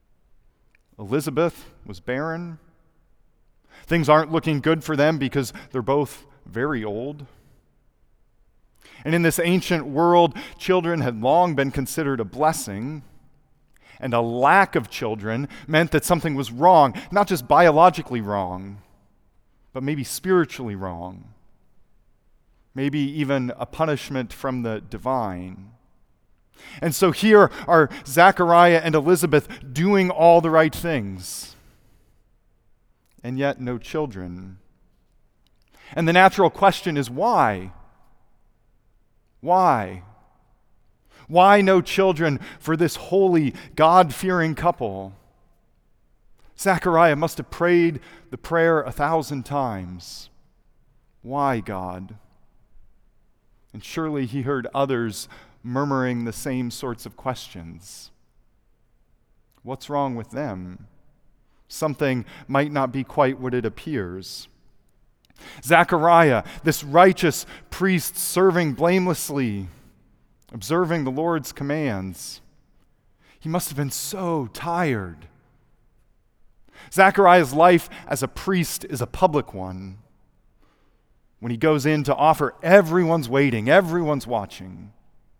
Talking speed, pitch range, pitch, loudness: 105 wpm, 115-165 Hz, 140 Hz, -20 LUFS